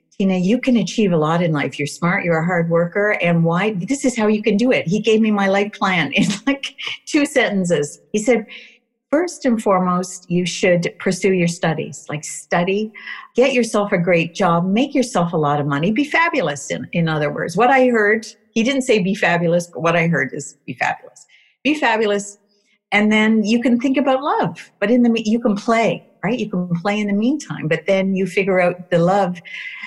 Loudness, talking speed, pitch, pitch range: -18 LUFS, 215 wpm, 205 Hz, 175-230 Hz